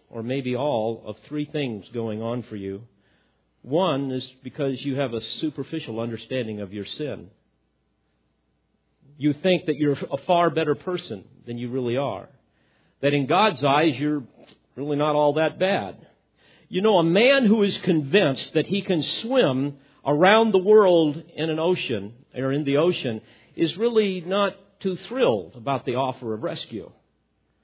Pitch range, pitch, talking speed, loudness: 120-175 Hz, 145 Hz, 160 wpm, -23 LUFS